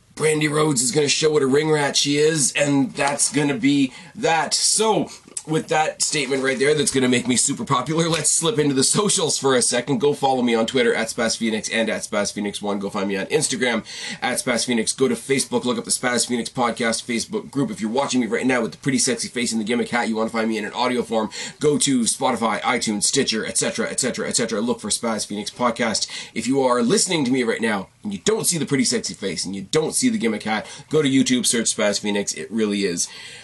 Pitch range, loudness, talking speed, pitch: 115-160 Hz, -20 LUFS, 245 wpm, 135 Hz